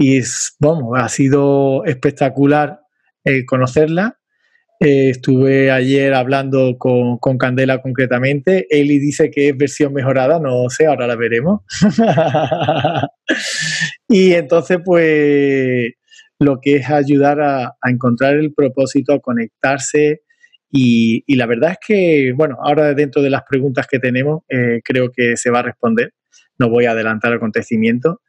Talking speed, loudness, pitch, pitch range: 145 wpm, -14 LUFS, 140 Hz, 130-155 Hz